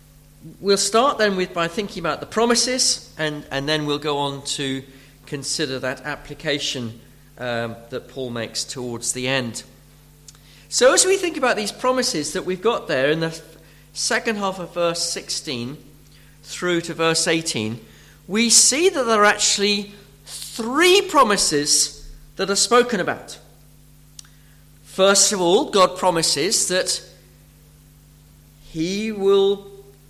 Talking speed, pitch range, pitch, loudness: 135 wpm, 140-200 Hz, 155 Hz, -19 LUFS